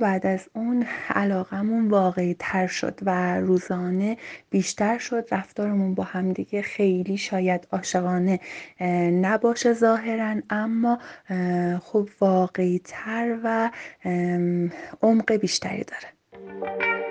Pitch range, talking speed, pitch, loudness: 180-220 Hz, 100 wpm, 190 Hz, -24 LUFS